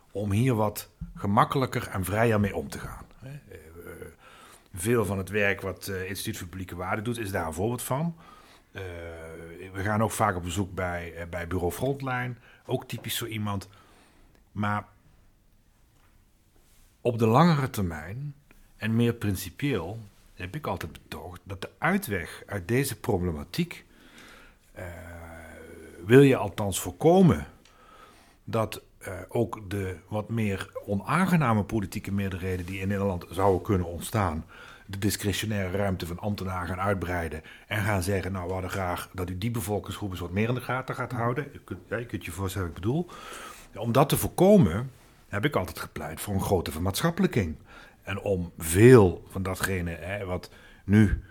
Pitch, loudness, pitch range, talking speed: 100 Hz, -27 LUFS, 90-115 Hz, 155 wpm